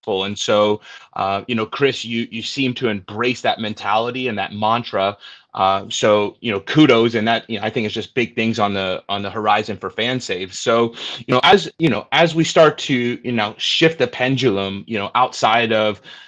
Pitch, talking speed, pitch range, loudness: 115 Hz, 210 wpm, 105-125 Hz, -18 LUFS